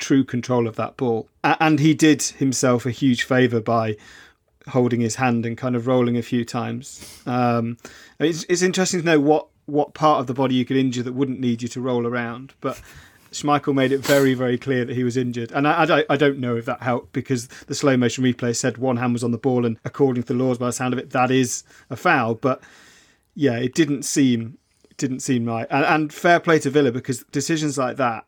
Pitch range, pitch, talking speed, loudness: 120-140 Hz, 130 Hz, 235 wpm, -21 LUFS